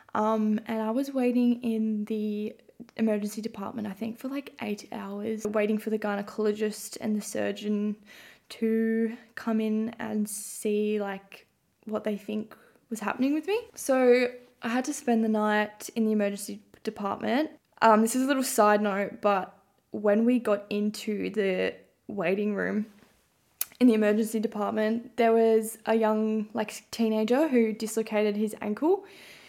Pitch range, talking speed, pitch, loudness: 210-230 Hz, 155 wpm, 220 Hz, -28 LUFS